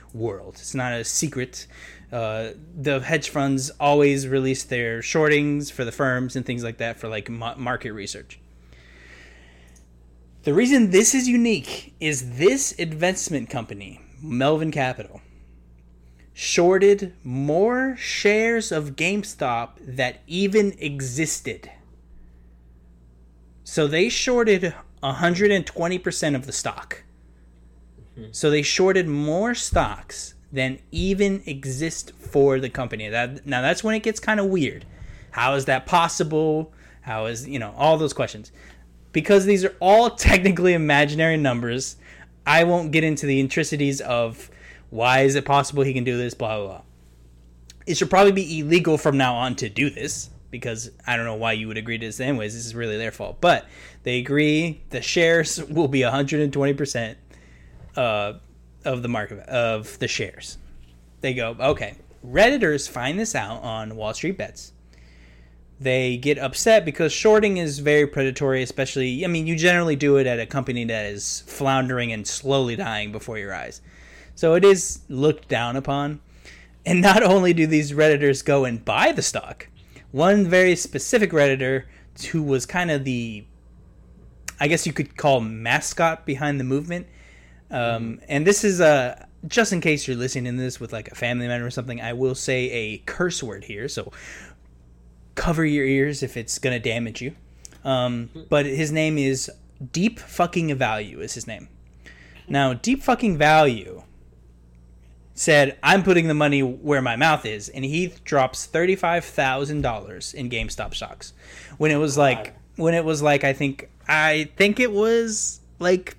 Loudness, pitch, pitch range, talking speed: -21 LUFS, 135 Hz, 110-155 Hz, 160 wpm